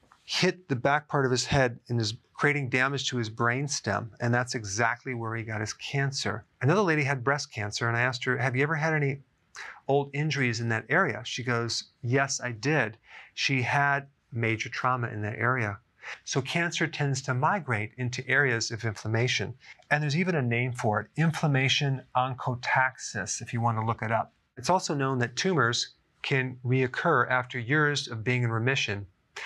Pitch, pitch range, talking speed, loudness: 130 Hz, 115-140 Hz, 185 wpm, -28 LUFS